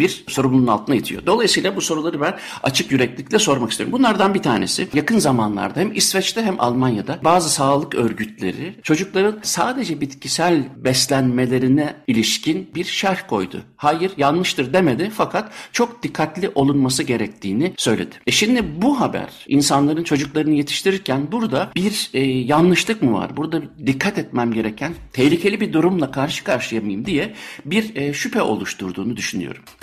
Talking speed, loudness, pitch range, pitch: 140 wpm, -19 LUFS, 135-190 Hz, 155 Hz